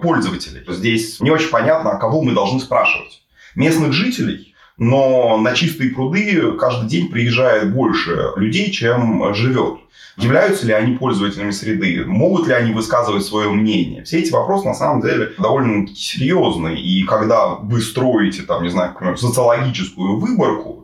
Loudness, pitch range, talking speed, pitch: -16 LUFS, 105-135 Hz, 145 wpm, 120 Hz